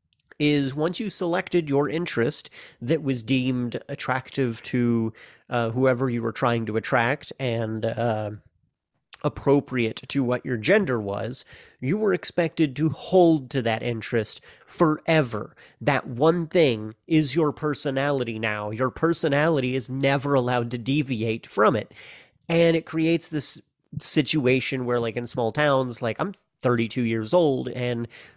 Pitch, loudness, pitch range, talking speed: 130 Hz, -24 LUFS, 120-155 Hz, 140 wpm